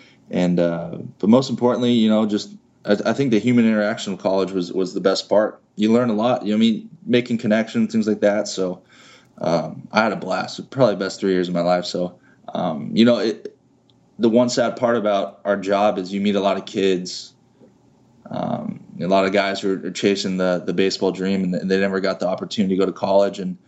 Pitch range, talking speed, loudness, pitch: 95-110 Hz, 225 wpm, -20 LUFS, 100 Hz